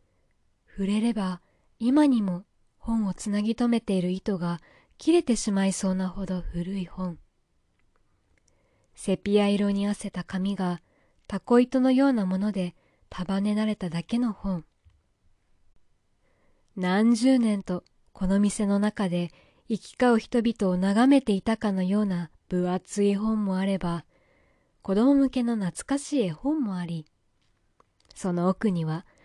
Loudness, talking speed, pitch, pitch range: -26 LUFS, 240 characters per minute, 195 Hz, 180-220 Hz